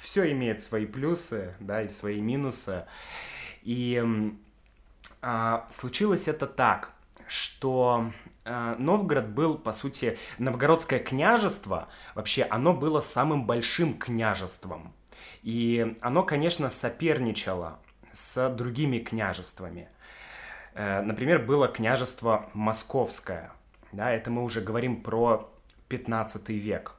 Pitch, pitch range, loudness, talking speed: 120 Hz, 110-135 Hz, -28 LUFS, 105 wpm